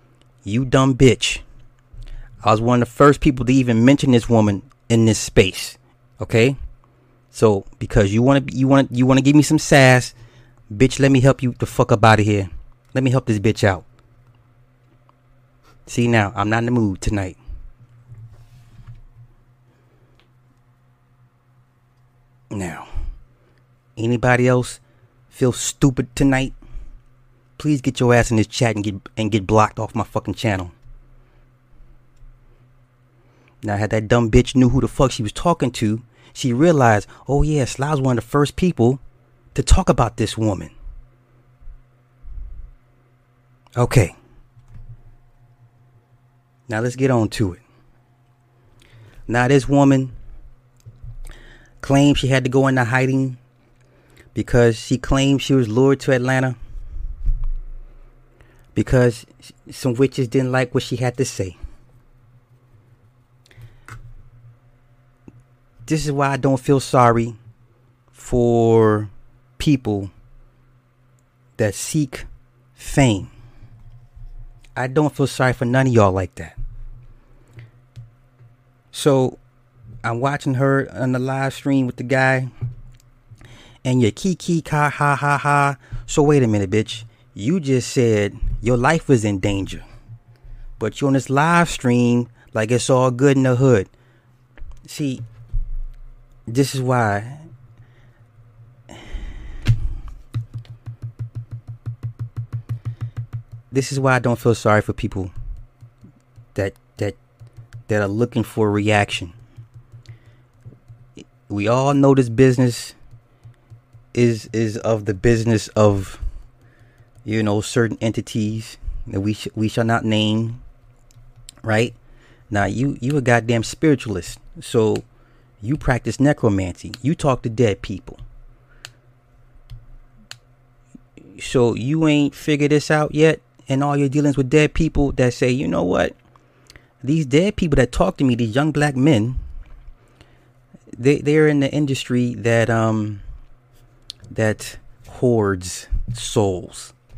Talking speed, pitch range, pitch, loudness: 125 wpm, 115-130 Hz, 120 Hz, -18 LUFS